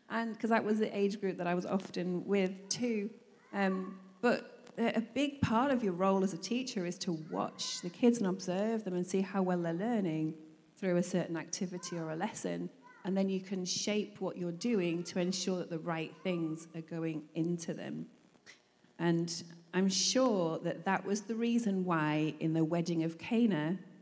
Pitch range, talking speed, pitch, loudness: 170-205 Hz, 190 wpm, 185 Hz, -34 LUFS